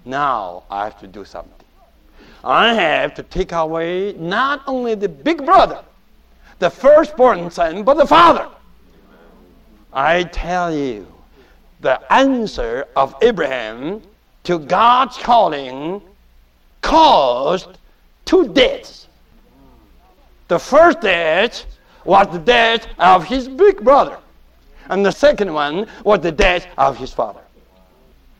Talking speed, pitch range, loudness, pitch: 115 wpm, 175-285 Hz, -15 LUFS, 210 Hz